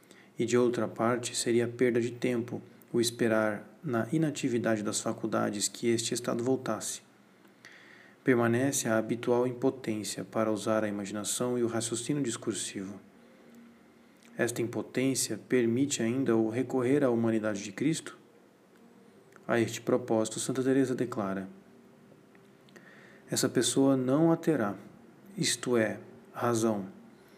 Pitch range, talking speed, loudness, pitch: 110-125 Hz, 120 wpm, -30 LUFS, 115 Hz